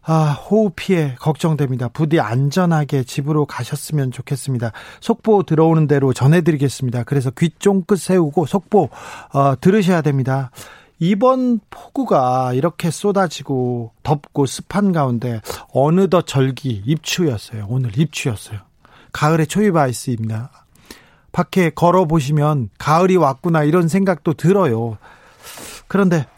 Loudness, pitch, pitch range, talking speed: -17 LUFS, 155 Hz, 130-180 Hz, 305 characters per minute